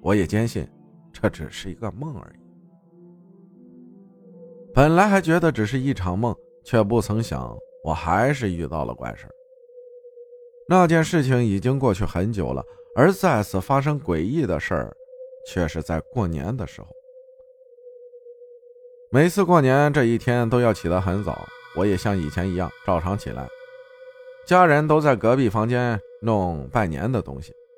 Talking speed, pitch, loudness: 220 characters per minute, 150 Hz, -22 LUFS